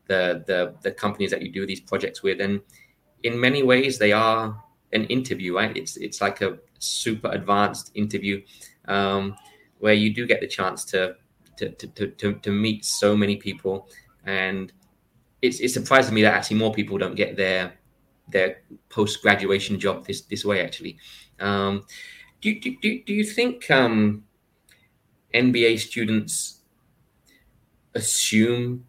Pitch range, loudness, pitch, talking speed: 100-120 Hz, -23 LUFS, 105 Hz, 150 wpm